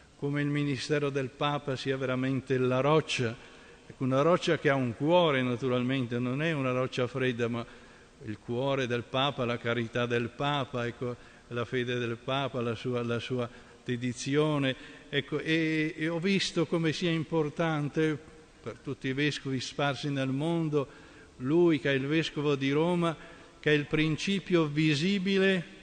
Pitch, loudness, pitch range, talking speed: 140 Hz, -30 LUFS, 125-155 Hz, 155 wpm